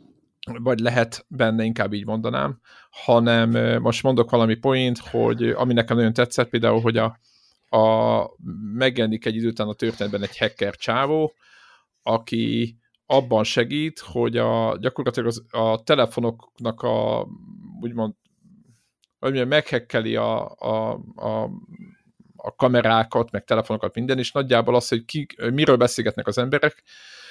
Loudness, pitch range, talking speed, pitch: -22 LUFS, 115-130 Hz, 125 wpm, 120 Hz